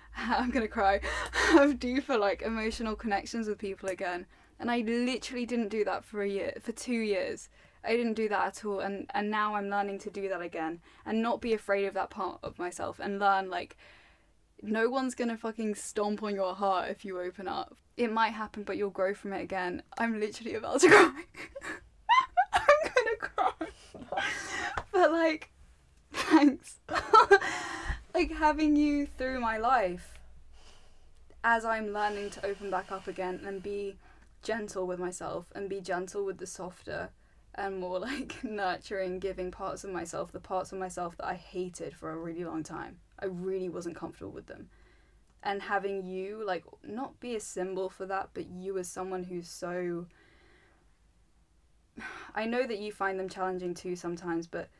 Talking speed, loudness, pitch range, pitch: 175 wpm, -31 LUFS, 185-230 Hz, 200 Hz